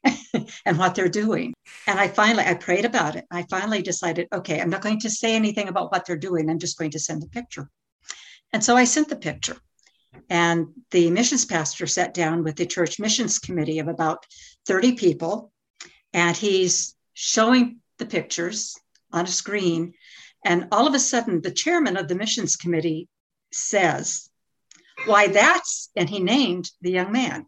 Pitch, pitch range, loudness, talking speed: 185 Hz, 170-225 Hz, -22 LUFS, 175 wpm